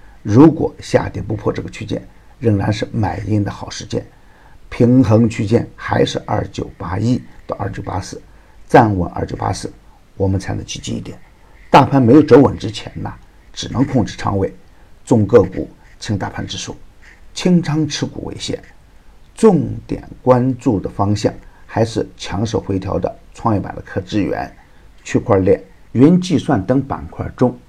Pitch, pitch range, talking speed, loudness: 115 Hz, 100-135 Hz, 235 characters per minute, -16 LUFS